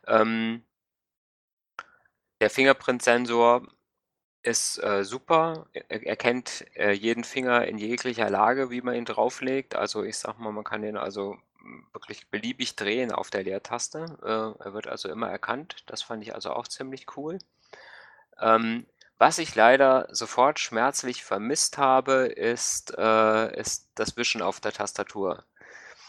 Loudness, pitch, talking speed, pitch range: -26 LUFS, 120 Hz, 140 wpm, 110-130 Hz